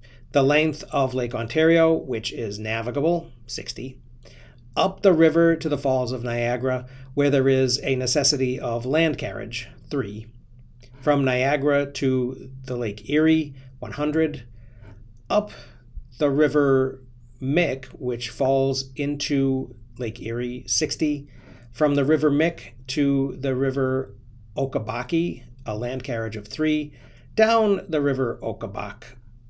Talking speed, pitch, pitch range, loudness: 120 wpm, 130 Hz, 120-145 Hz, -23 LUFS